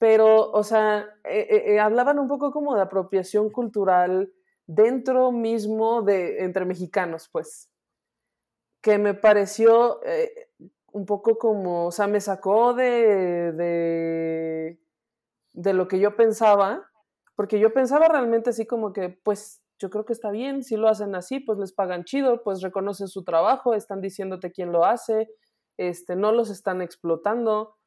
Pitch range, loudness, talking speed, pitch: 190-230 Hz, -23 LUFS, 155 wpm, 210 Hz